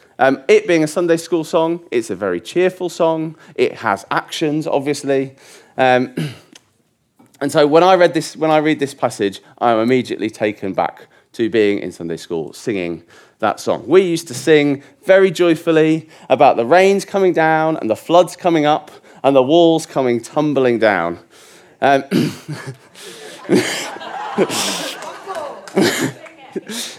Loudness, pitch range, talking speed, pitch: -16 LUFS, 130-170 Hz, 145 wpm, 155 Hz